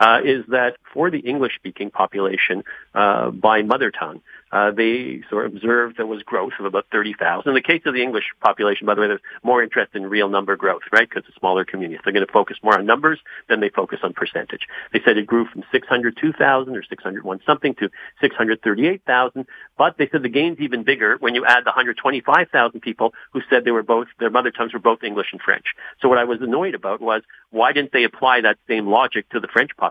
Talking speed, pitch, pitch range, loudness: 230 wpm, 115 Hz, 105-130 Hz, -19 LUFS